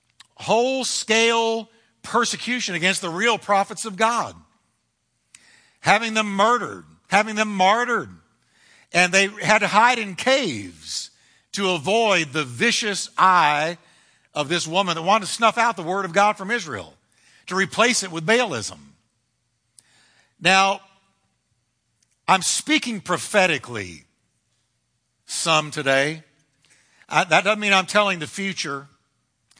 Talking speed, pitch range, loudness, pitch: 120 wpm, 165-220 Hz, -20 LUFS, 195 Hz